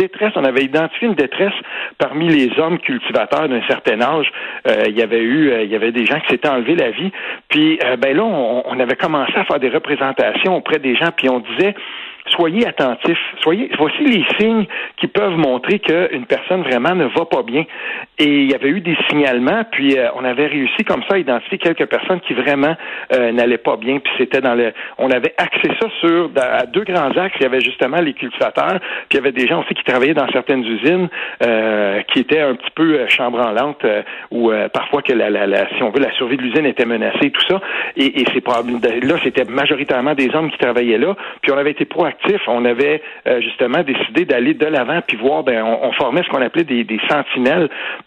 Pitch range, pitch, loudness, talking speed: 125-185 Hz, 145 Hz, -16 LUFS, 225 wpm